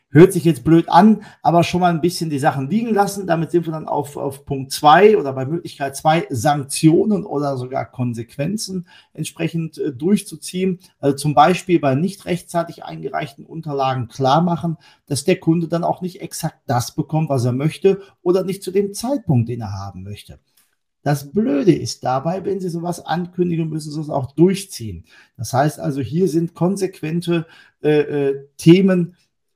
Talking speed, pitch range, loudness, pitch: 175 wpm, 140-180 Hz, -18 LUFS, 160 Hz